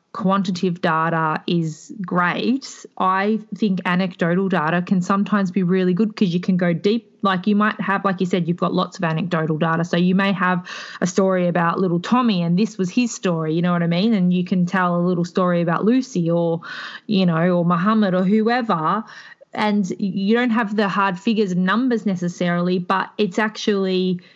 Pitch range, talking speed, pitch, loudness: 175-210 Hz, 195 wpm, 190 Hz, -20 LUFS